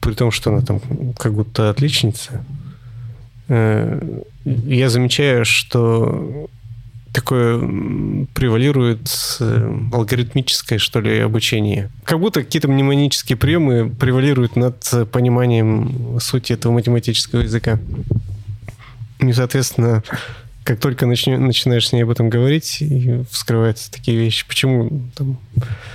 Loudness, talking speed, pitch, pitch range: -17 LUFS, 100 wpm, 120 Hz, 115-130 Hz